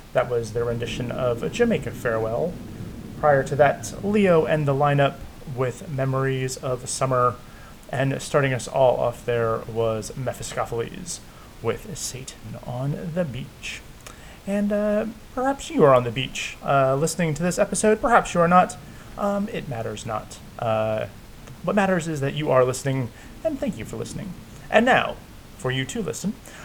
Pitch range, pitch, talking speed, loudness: 120-180 Hz, 135 Hz, 160 wpm, -23 LUFS